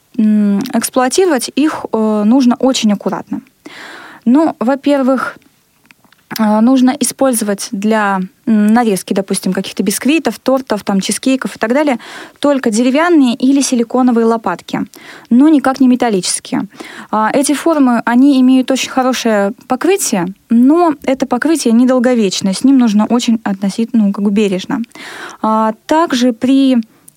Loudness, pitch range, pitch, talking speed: -12 LUFS, 215-270 Hz, 245 Hz, 110 wpm